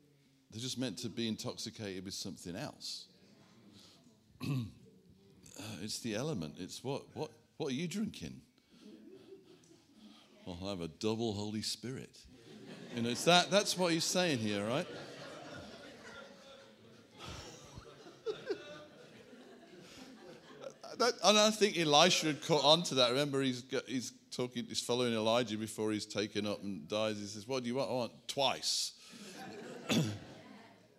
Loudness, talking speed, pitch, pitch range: -34 LUFS, 130 wpm, 125 Hz, 110-155 Hz